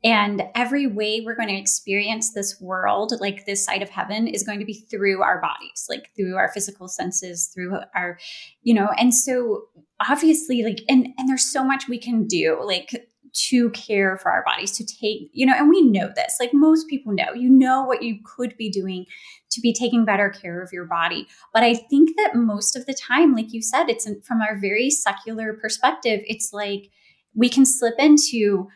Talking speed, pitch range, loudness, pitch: 205 wpm, 200-255 Hz, -20 LUFS, 225 Hz